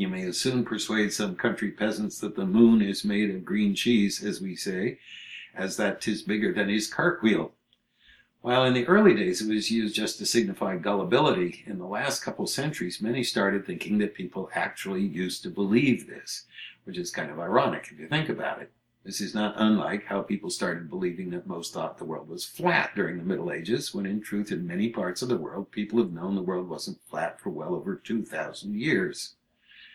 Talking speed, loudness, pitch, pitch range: 205 wpm, -27 LUFS, 105 Hz, 100-120 Hz